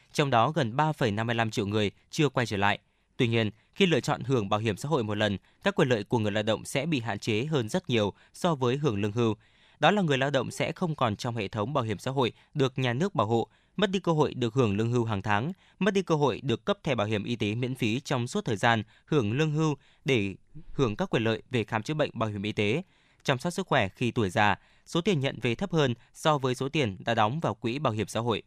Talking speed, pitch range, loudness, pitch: 270 wpm, 110-150 Hz, -28 LUFS, 125 Hz